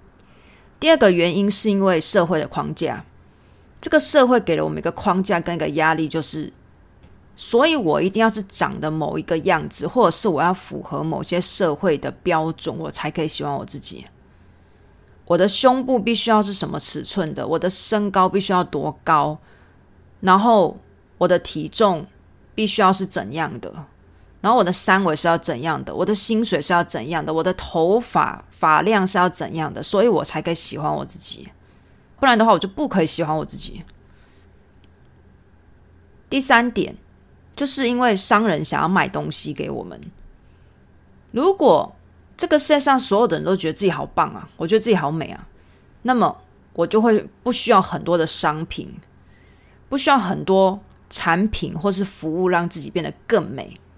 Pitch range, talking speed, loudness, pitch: 160-215 Hz, 260 characters per minute, -19 LUFS, 180 Hz